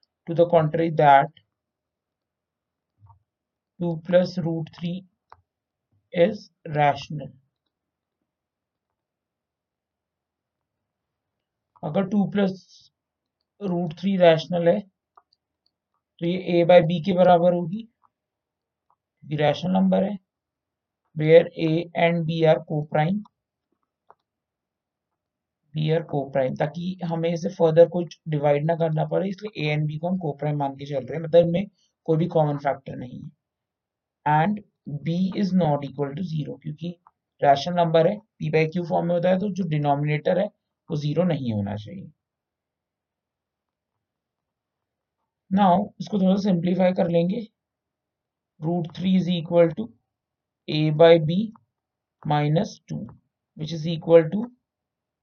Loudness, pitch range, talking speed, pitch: -22 LUFS, 145-180 Hz, 100 wpm, 165 Hz